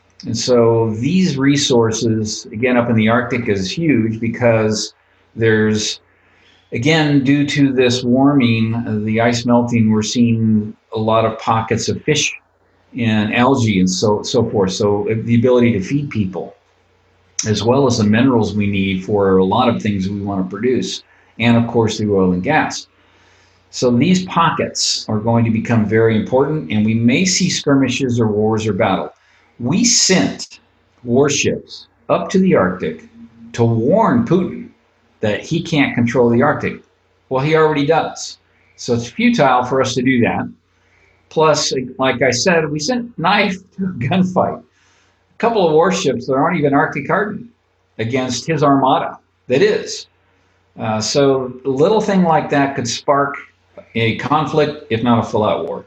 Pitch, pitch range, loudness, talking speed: 120 Hz, 110-145 Hz, -16 LUFS, 160 wpm